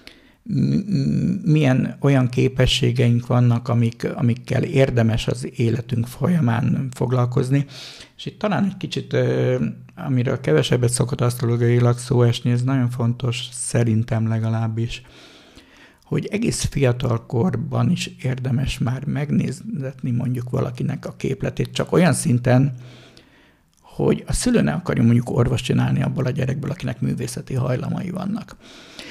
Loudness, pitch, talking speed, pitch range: -21 LUFS, 125 Hz, 115 wpm, 120-135 Hz